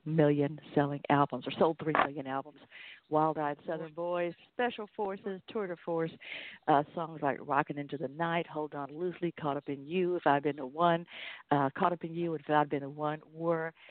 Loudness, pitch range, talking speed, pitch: -33 LUFS, 145-170 Hz, 210 wpm, 155 Hz